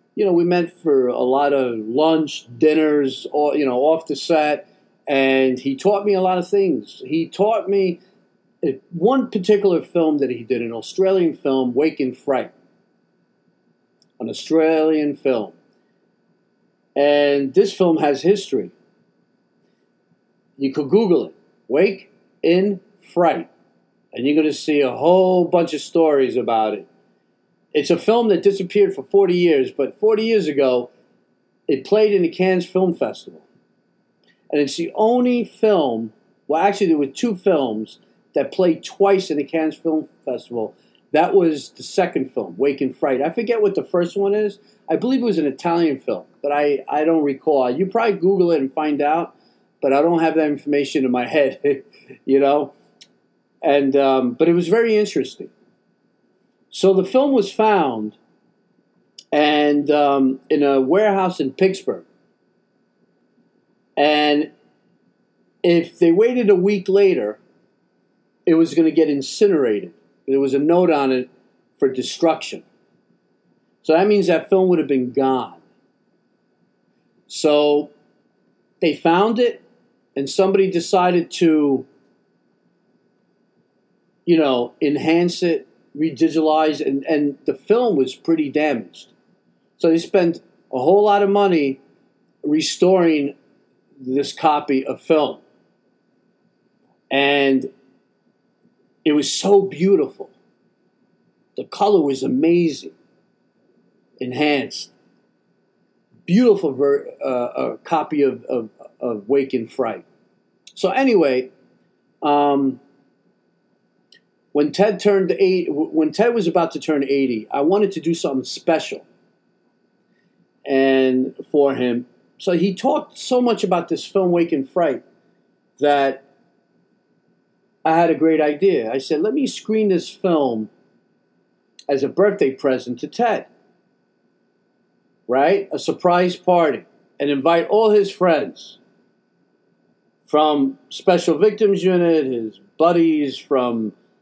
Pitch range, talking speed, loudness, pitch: 140-195 Hz, 135 wpm, -18 LUFS, 160 Hz